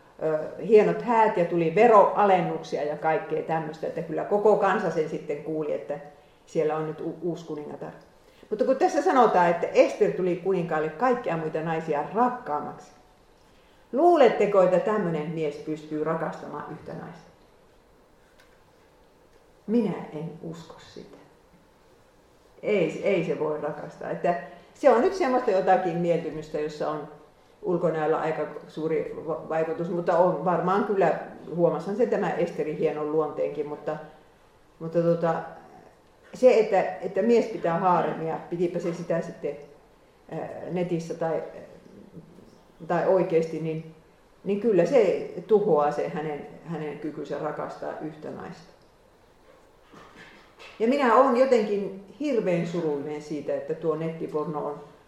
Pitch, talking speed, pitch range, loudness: 170 Hz, 125 wpm, 155-205 Hz, -25 LUFS